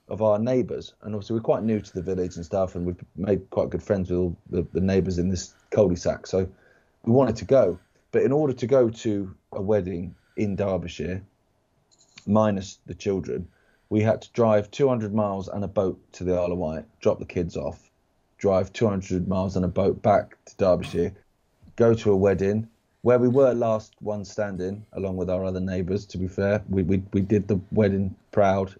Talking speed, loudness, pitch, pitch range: 200 wpm, -25 LUFS, 100 Hz, 95-110 Hz